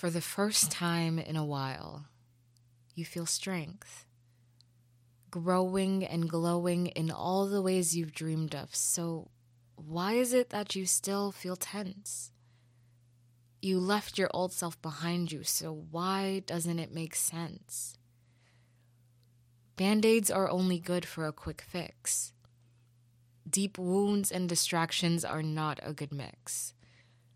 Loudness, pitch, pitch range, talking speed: -32 LUFS, 165 Hz, 120-180 Hz, 130 wpm